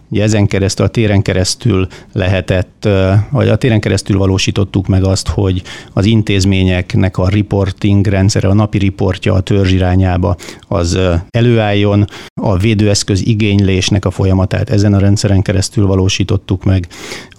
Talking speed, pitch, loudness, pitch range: 135 wpm, 100 Hz, -12 LUFS, 95-105 Hz